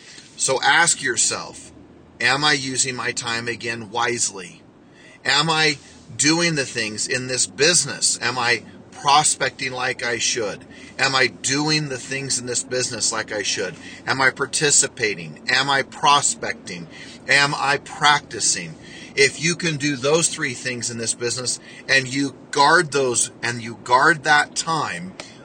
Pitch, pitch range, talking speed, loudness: 130 Hz, 120-145 Hz, 150 wpm, -19 LUFS